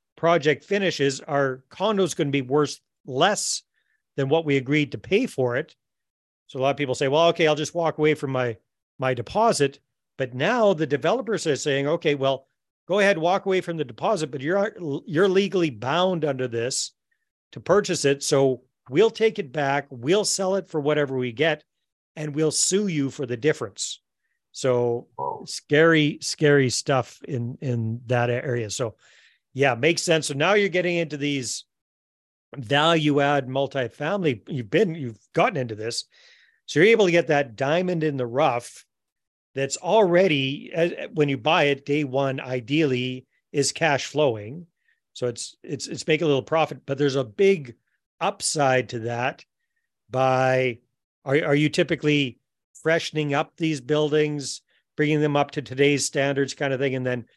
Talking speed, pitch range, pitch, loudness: 170 wpm, 130-165 Hz, 145 Hz, -23 LUFS